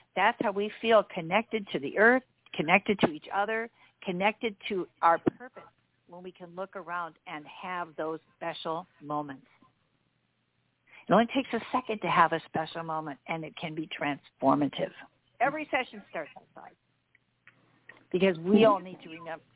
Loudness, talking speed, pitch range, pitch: -29 LUFS, 155 wpm, 165-215 Hz, 185 Hz